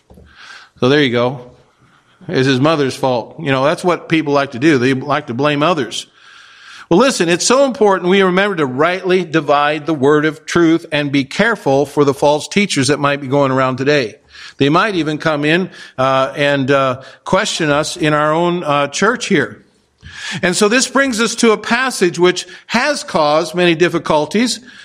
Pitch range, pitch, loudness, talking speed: 140-185 Hz, 155 Hz, -14 LUFS, 185 wpm